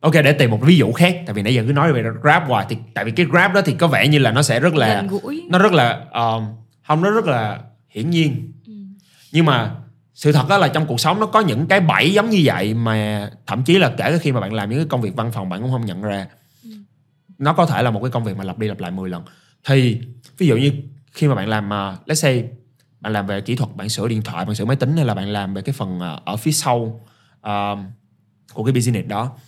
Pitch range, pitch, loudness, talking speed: 110-155 Hz, 130 Hz, -18 LUFS, 270 wpm